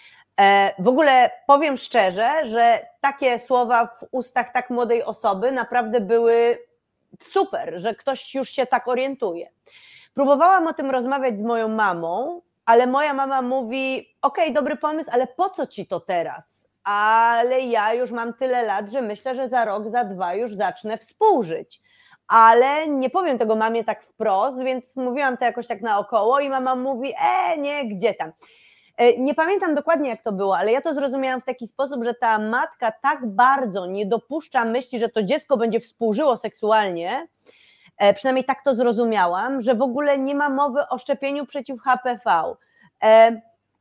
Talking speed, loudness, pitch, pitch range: 160 wpm, -21 LUFS, 255 Hz, 230-280 Hz